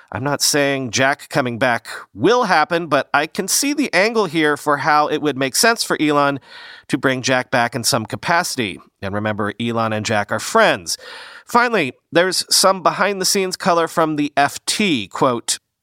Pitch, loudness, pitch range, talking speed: 150 Hz, -17 LUFS, 130-190 Hz, 180 wpm